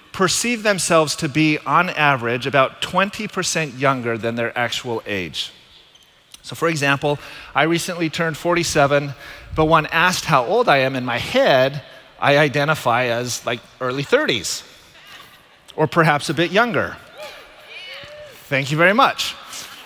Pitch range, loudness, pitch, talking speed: 130-170 Hz, -18 LUFS, 150 Hz, 135 wpm